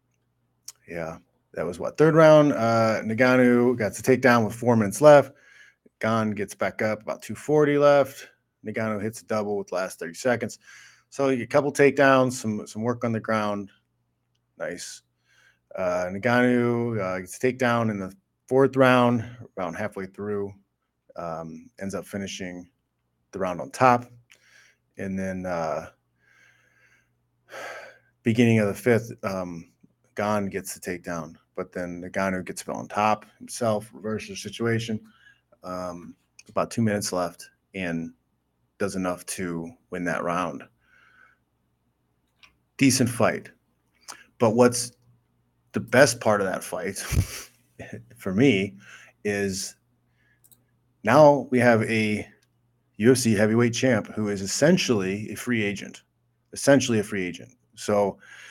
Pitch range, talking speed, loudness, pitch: 90-120 Hz, 135 wpm, -24 LUFS, 105 Hz